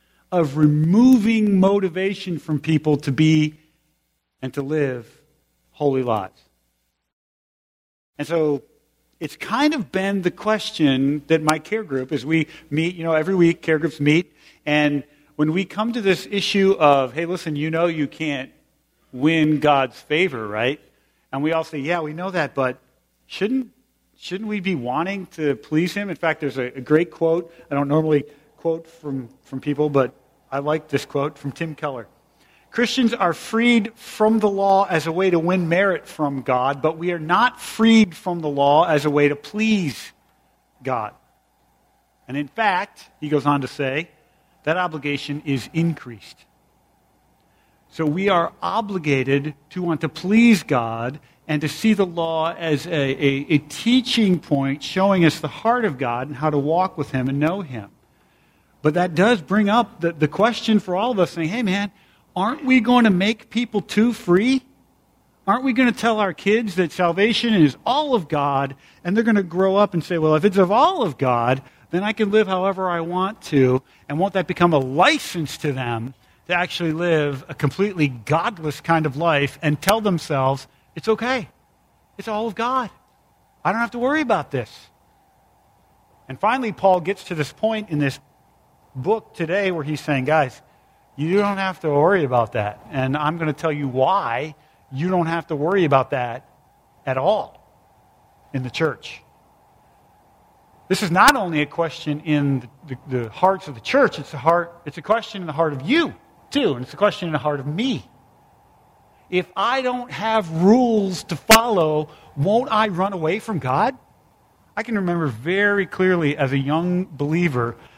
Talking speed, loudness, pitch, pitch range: 180 wpm, -20 LUFS, 160 Hz, 145-195 Hz